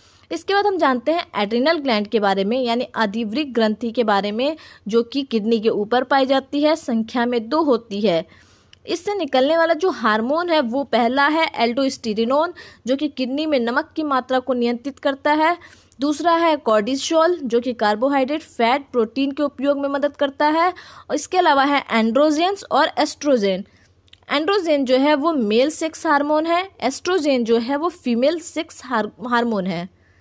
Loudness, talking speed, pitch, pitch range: -20 LUFS, 170 wpm, 275 Hz, 235-310 Hz